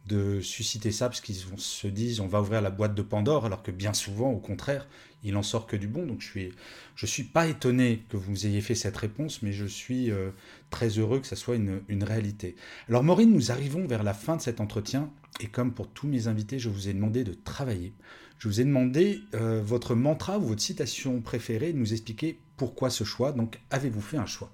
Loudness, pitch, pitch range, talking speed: -29 LUFS, 115 Hz, 105-130 Hz, 230 wpm